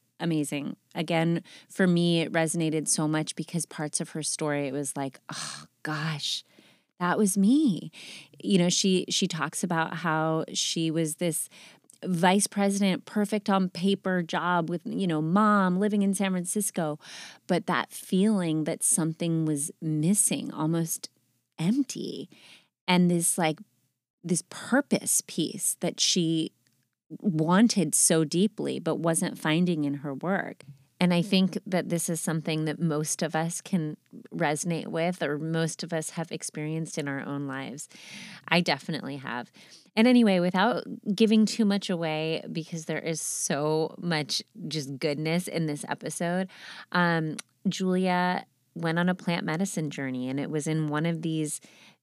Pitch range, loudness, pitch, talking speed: 155-190 Hz, -27 LUFS, 170 Hz, 150 wpm